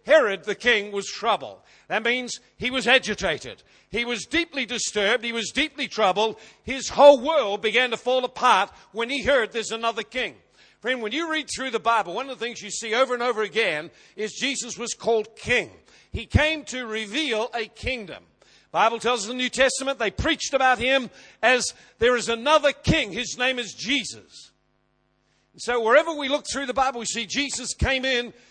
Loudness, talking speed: -23 LUFS, 195 wpm